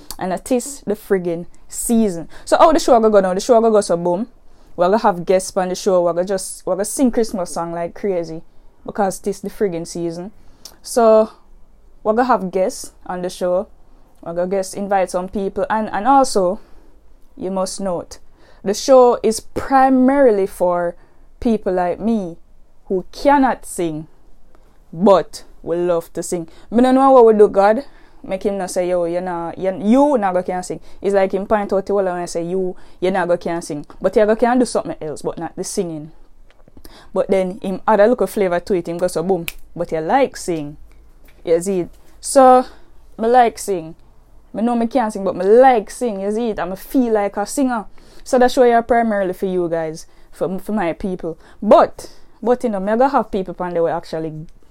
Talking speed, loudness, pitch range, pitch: 205 wpm, -17 LUFS, 175-230 Hz, 195 Hz